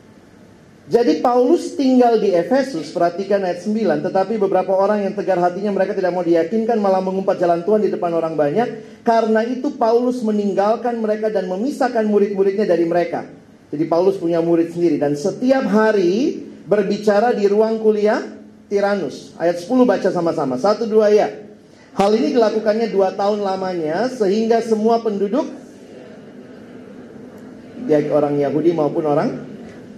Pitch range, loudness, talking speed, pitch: 185-230 Hz, -18 LUFS, 140 wpm, 205 Hz